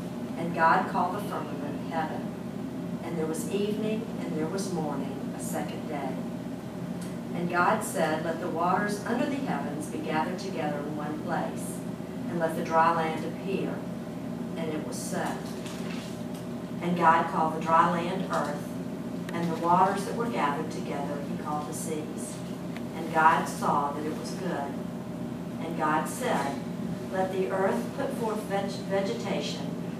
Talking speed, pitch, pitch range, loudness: 155 wpm, 190 Hz, 170-205 Hz, -30 LUFS